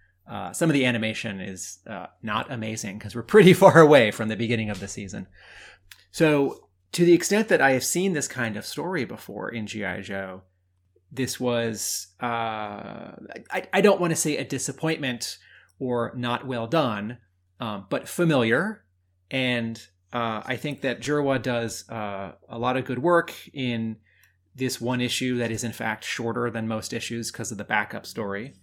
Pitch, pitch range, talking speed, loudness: 120 Hz, 105-135 Hz, 175 wpm, -24 LUFS